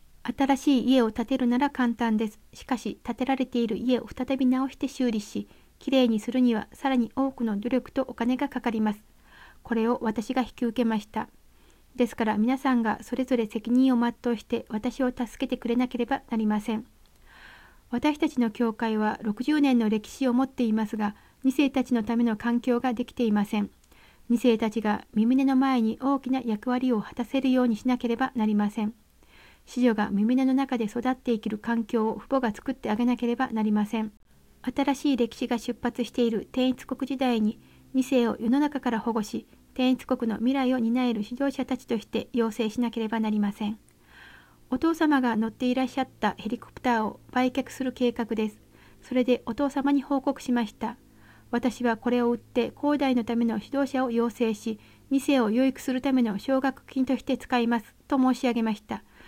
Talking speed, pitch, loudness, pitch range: 360 characters per minute, 245 Hz, -27 LUFS, 225-260 Hz